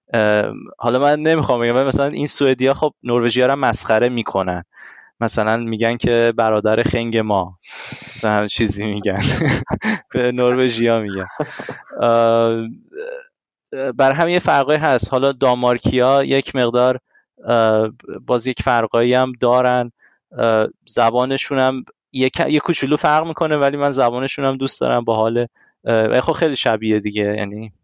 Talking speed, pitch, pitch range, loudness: 130 wpm, 125 Hz, 115-135 Hz, -17 LUFS